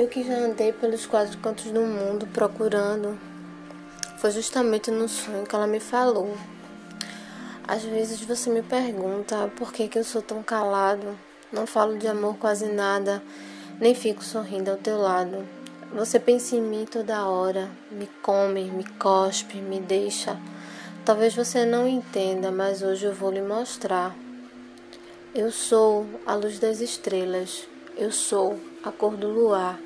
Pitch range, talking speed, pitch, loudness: 195-225 Hz, 155 wpm, 210 Hz, -25 LUFS